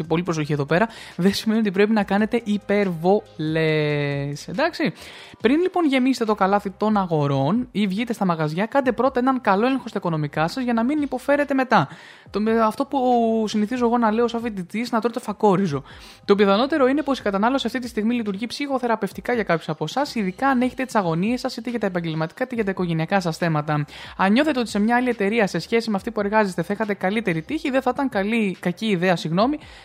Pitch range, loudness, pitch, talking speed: 185-245 Hz, -22 LUFS, 215 Hz, 205 wpm